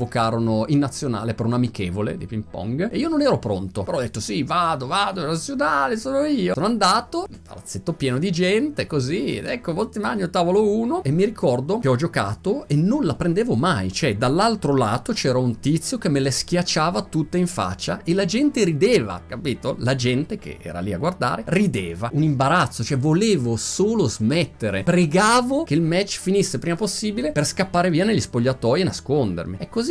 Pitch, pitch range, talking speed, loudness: 165 Hz, 125-200 Hz, 195 wpm, -21 LUFS